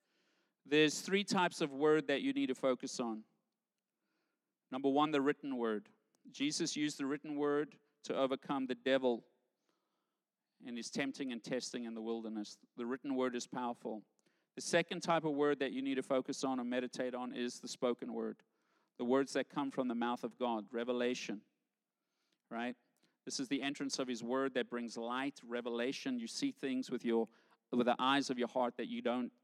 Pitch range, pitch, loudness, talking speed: 120-140 Hz, 130 Hz, -38 LUFS, 190 wpm